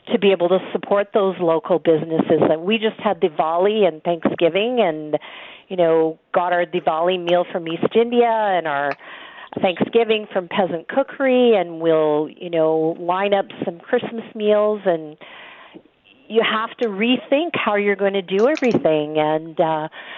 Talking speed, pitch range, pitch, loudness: 160 wpm, 165-220 Hz, 190 Hz, -19 LUFS